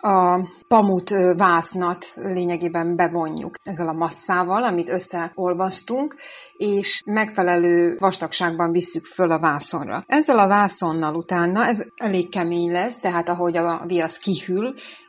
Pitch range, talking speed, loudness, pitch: 170-200 Hz, 120 wpm, -21 LUFS, 180 Hz